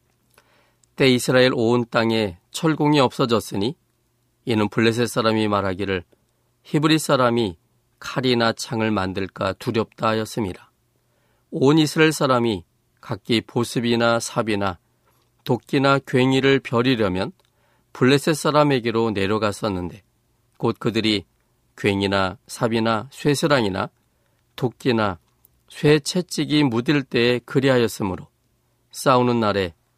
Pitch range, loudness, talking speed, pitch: 110-135 Hz, -21 LUFS, 260 characters per minute, 120 Hz